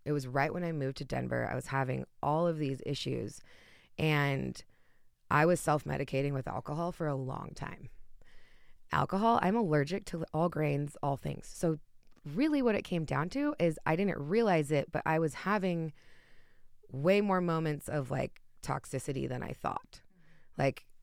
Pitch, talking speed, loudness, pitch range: 155 Hz, 170 wpm, -33 LUFS, 140-175 Hz